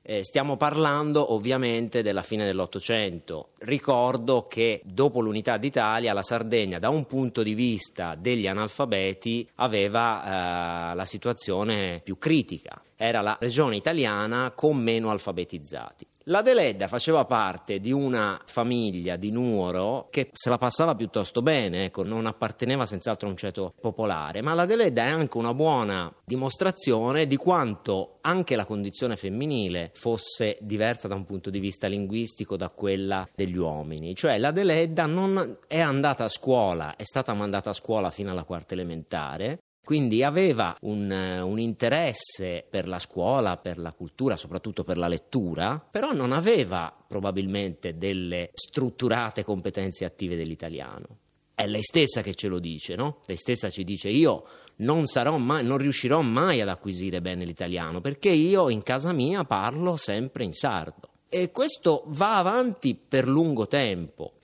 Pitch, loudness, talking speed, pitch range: 110 Hz, -26 LUFS, 150 wpm, 95-130 Hz